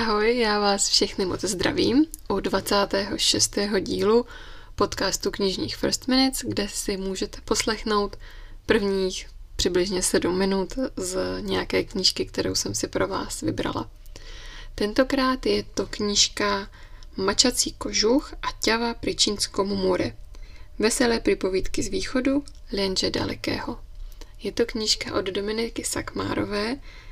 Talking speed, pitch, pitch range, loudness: 115 wpm, 215 Hz, 195-260 Hz, -24 LUFS